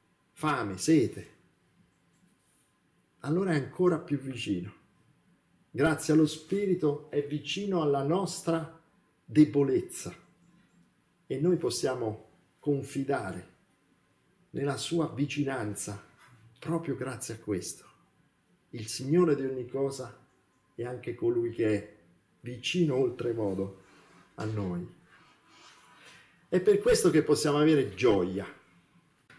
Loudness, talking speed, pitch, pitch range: -30 LUFS, 95 wpm, 145 Hz, 115-165 Hz